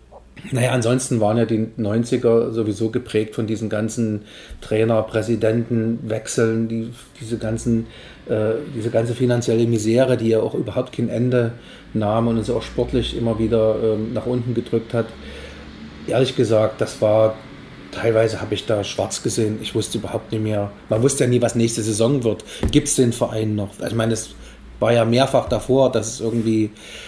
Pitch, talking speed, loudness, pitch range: 115 Hz, 170 wpm, -20 LUFS, 110-120 Hz